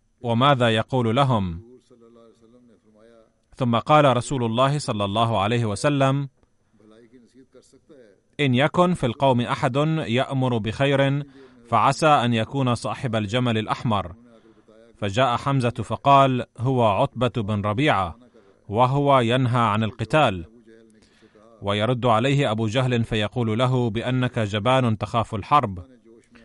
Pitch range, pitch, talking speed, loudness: 110-135 Hz, 120 Hz, 100 wpm, -21 LUFS